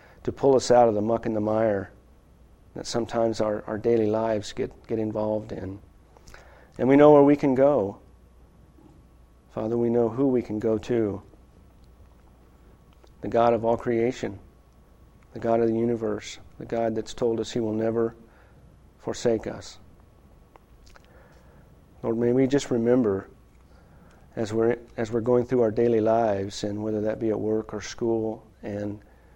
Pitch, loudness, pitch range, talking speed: 110 Hz, -24 LUFS, 105-120 Hz, 160 wpm